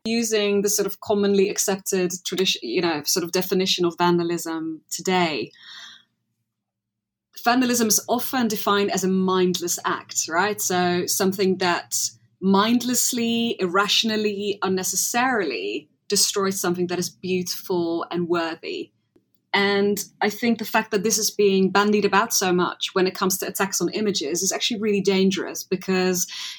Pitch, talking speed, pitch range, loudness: 195 Hz, 140 wpm, 180-210 Hz, -22 LUFS